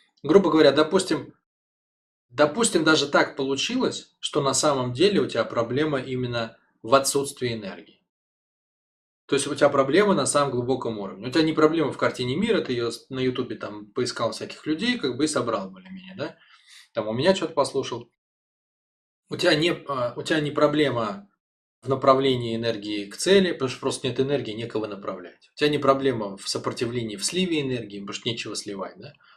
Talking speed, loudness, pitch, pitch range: 175 wpm, -24 LUFS, 135 Hz, 120-155 Hz